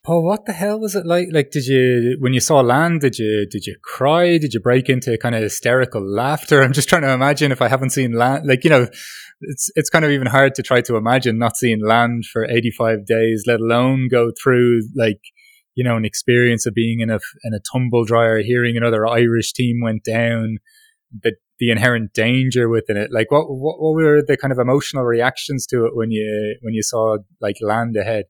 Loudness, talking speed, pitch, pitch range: -17 LUFS, 225 wpm, 120 Hz, 115-135 Hz